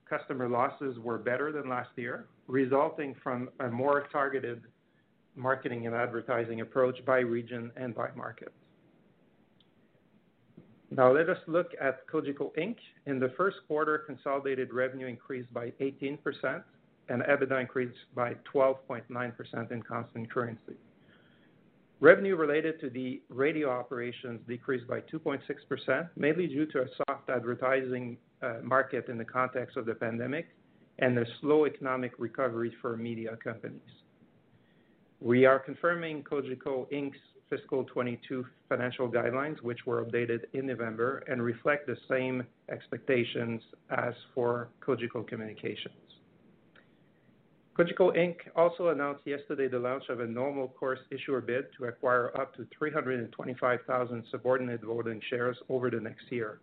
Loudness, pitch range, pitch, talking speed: -32 LUFS, 120-140 Hz, 130 Hz, 130 wpm